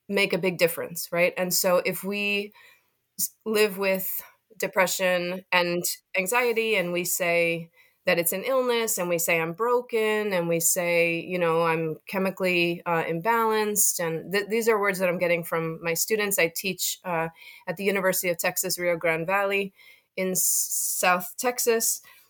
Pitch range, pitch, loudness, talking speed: 175-205 Hz, 185 Hz, -24 LUFS, 165 wpm